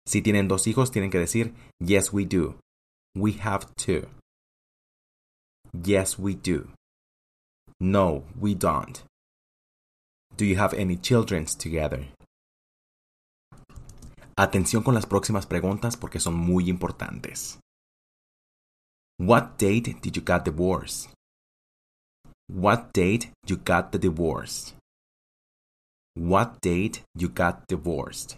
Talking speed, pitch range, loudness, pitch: 110 wpm, 85-105 Hz, -25 LUFS, 95 Hz